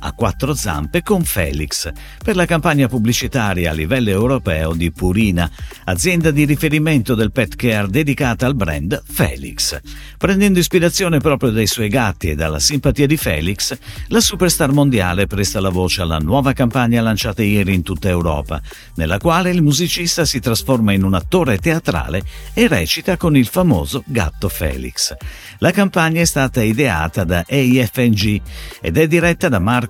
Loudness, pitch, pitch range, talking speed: -16 LUFS, 120 Hz, 95-155 Hz, 155 wpm